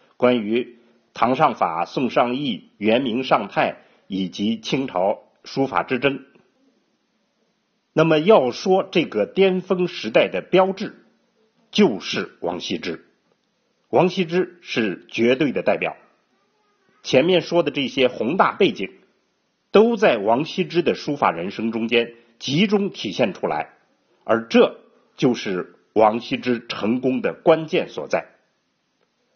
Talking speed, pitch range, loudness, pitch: 180 characters per minute, 125-190 Hz, -21 LUFS, 160 Hz